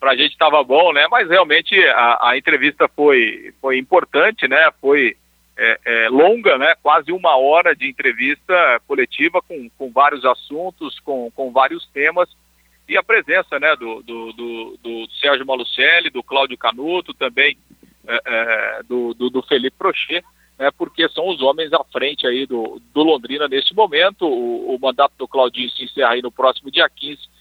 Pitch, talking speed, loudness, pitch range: 135 Hz, 175 wpm, -16 LUFS, 120-165 Hz